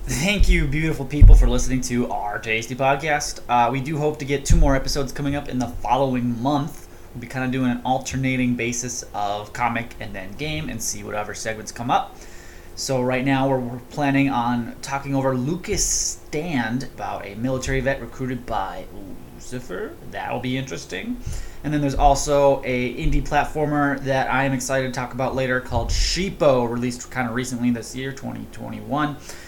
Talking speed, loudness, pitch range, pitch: 180 wpm, -23 LUFS, 120-140 Hz, 130 Hz